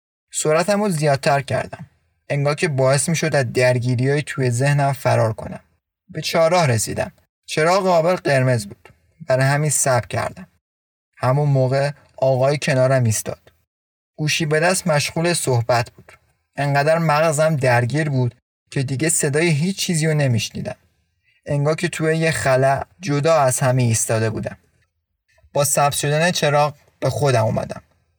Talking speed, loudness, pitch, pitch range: 140 wpm, -19 LUFS, 135 Hz, 120-155 Hz